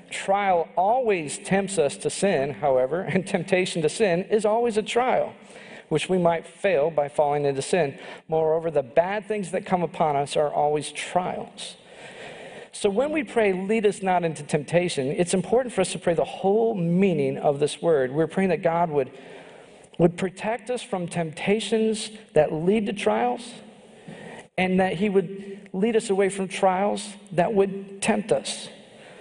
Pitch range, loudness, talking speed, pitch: 170-215 Hz, -24 LUFS, 170 wpm, 190 Hz